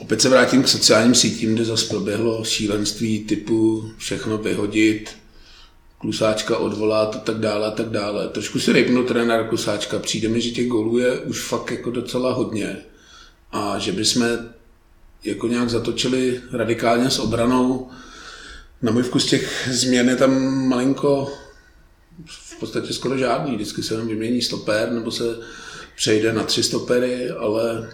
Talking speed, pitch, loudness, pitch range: 150 wpm, 115 Hz, -20 LUFS, 110-125 Hz